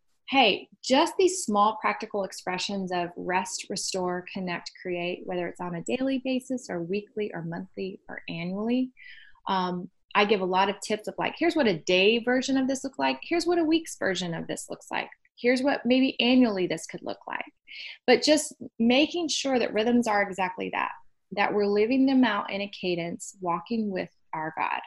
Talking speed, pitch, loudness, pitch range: 190 wpm, 205 Hz, -27 LUFS, 185-255 Hz